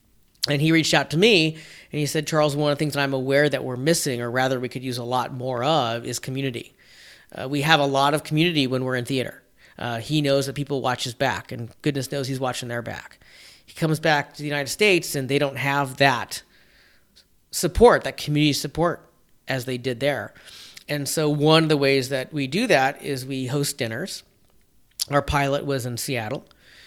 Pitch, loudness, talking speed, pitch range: 140 Hz, -22 LUFS, 215 wpm, 130-150 Hz